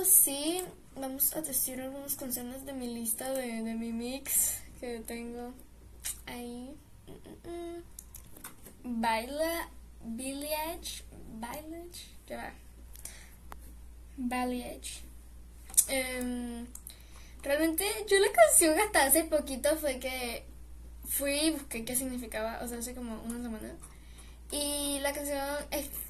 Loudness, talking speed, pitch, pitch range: -31 LUFS, 105 wpm, 255 Hz, 230-290 Hz